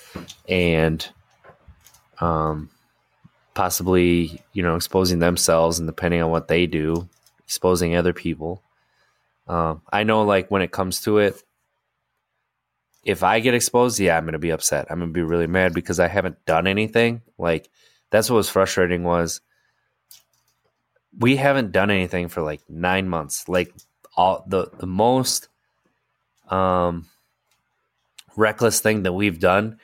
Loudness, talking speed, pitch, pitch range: -21 LUFS, 140 wpm, 90 Hz, 85-100 Hz